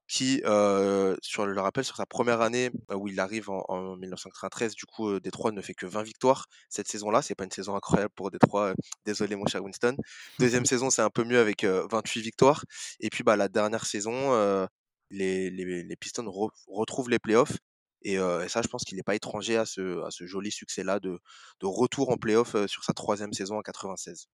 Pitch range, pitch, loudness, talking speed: 95-115 Hz, 105 Hz, -29 LUFS, 225 wpm